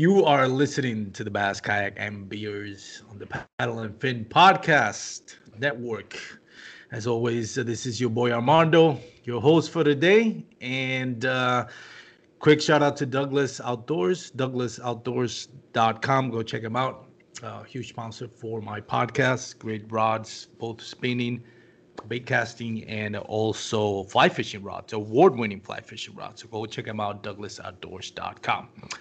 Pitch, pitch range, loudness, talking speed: 120 Hz, 110-130 Hz, -25 LUFS, 145 wpm